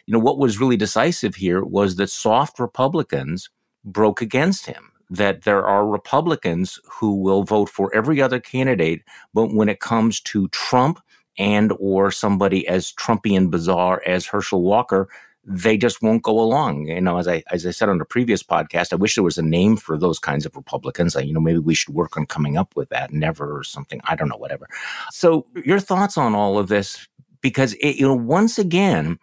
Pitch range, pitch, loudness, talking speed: 90-120 Hz, 105 Hz, -20 LUFS, 205 wpm